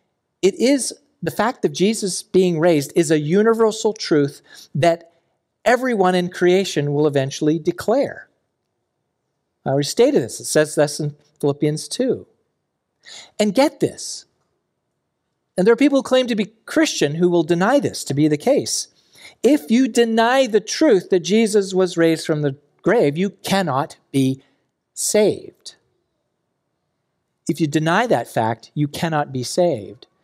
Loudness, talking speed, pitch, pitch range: -19 LUFS, 145 wpm, 175 Hz, 150-215 Hz